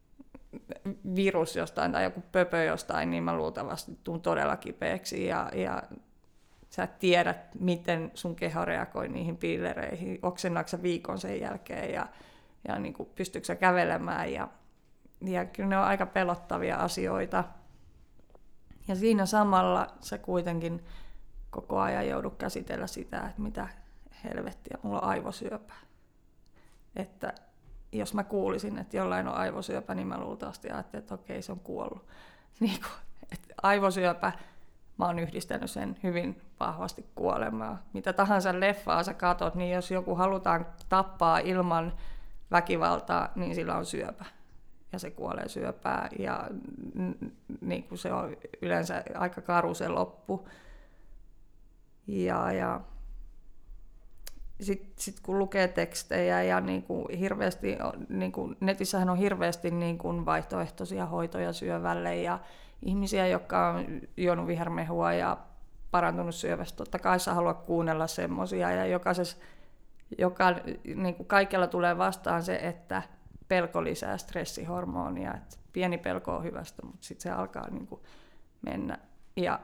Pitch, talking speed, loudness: 175 Hz, 125 wpm, -31 LUFS